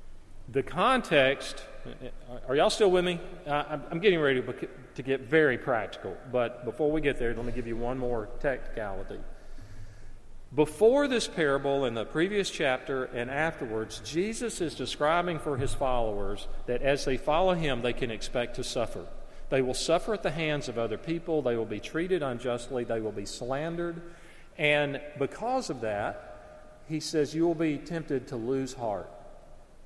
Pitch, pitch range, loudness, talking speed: 135 Hz, 120-165 Hz, -29 LUFS, 165 wpm